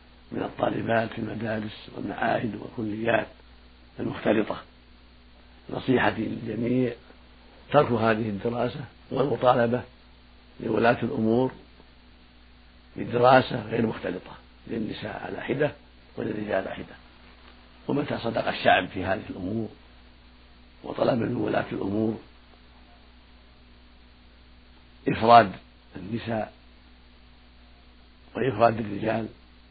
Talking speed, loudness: 75 wpm, -26 LUFS